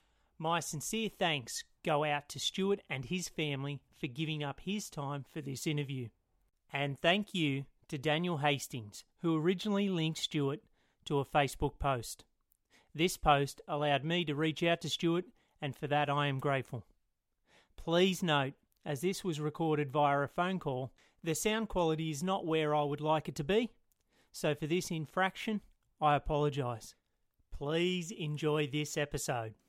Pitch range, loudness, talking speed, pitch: 140-170 Hz, -34 LUFS, 160 wpm, 150 Hz